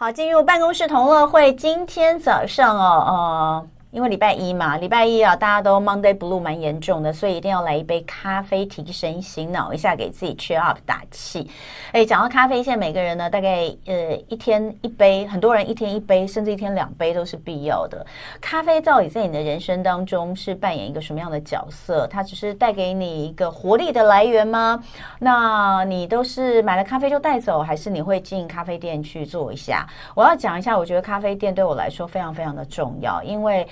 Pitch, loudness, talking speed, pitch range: 195 Hz, -20 LUFS, 340 characters per minute, 170-225 Hz